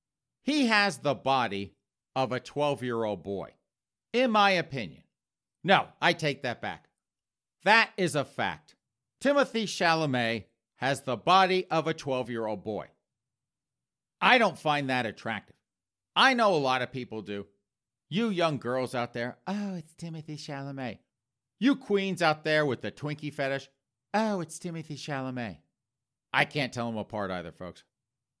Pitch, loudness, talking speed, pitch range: 135 Hz, -28 LUFS, 155 wpm, 120-170 Hz